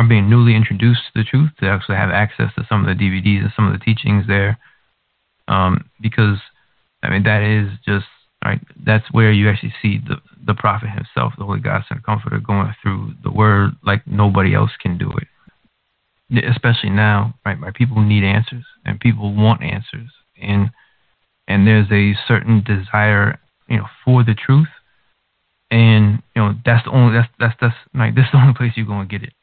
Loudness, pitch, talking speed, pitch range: -16 LUFS, 110 Hz, 195 wpm, 100-120 Hz